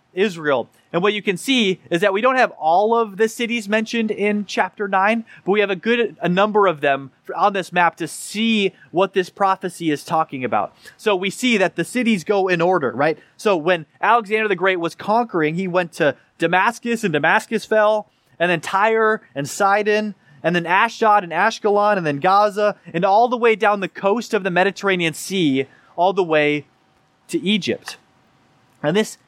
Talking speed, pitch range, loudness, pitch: 195 wpm, 170-215 Hz, -19 LUFS, 195 Hz